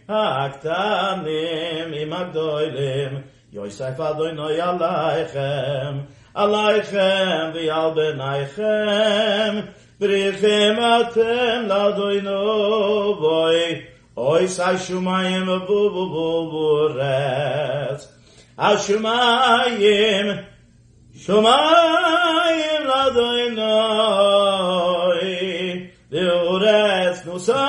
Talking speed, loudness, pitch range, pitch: 60 wpm, -19 LUFS, 160-210 Hz, 185 Hz